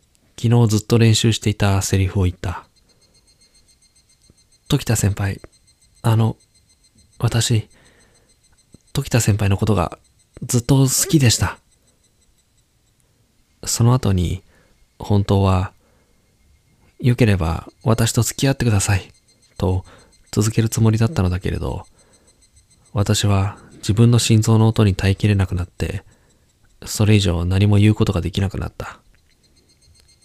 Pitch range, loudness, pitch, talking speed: 95-115 Hz, -18 LUFS, 105 Hz, 230 characters per minute